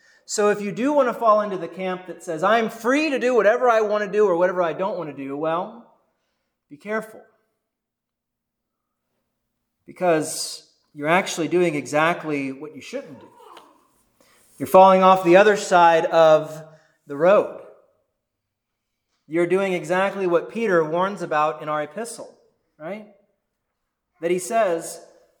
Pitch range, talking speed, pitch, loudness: 165-215 Hz, 150 wpm, 185 Hz, -20 LUFS